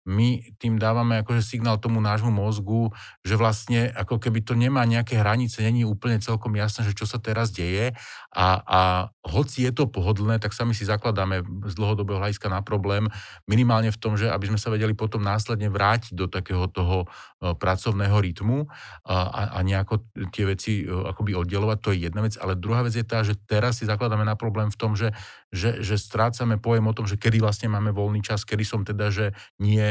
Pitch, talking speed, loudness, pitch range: 110 Hz, 200 wpm, -24 LUFS, 100-115 Hz